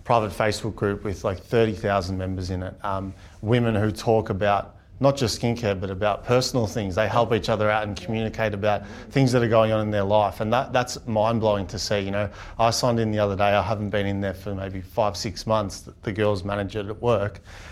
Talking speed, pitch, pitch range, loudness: 225 wpm, 105 Hz, 100-115 Hz, -24 LUFS